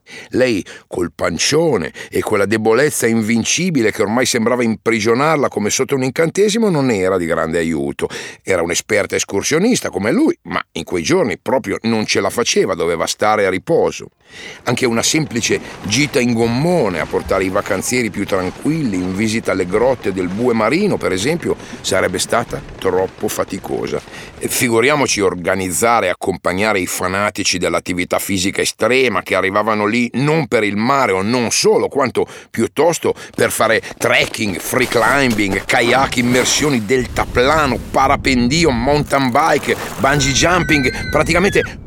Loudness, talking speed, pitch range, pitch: -16 LUFS, 140 wpm, 105-140 Hz, 120 Hz